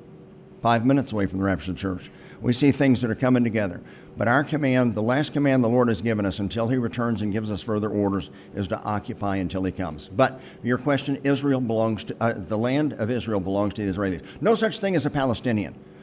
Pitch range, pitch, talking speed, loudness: 100-130 Hz, 115 Hz, 230 wpm, -24 LUFS